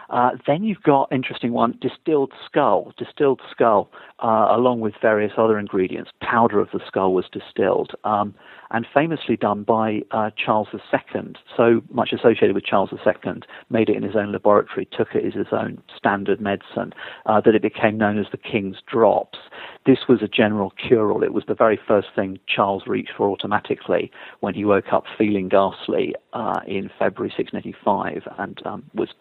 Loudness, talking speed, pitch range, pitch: -21 LUFS, 180 wpm, 105-120 Hz, 110 Hz